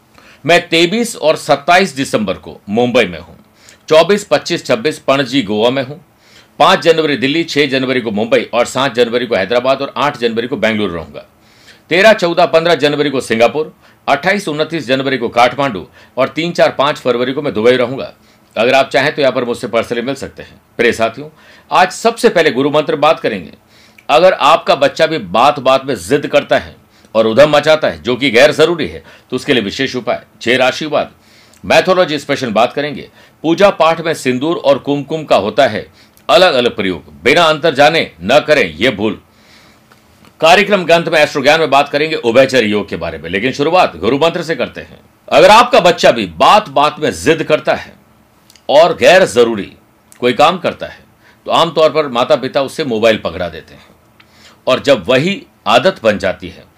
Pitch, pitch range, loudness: 140 Hz, 120-160 Hz, -12 LUFS